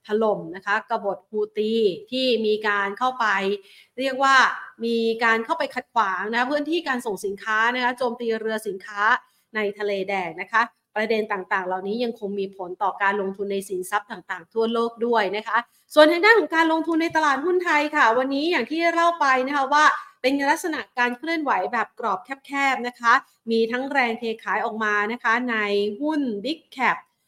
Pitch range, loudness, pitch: 205-270 Hz, -22 LUFS, 230 Hz